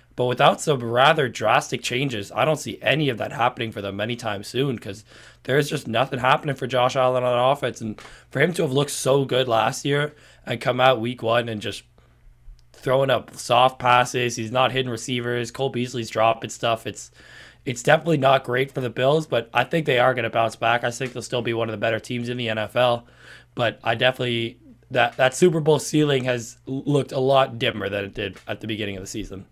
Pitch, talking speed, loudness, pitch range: 125 Hz, 220 wpm, -22 LUFS, 115-135 Hz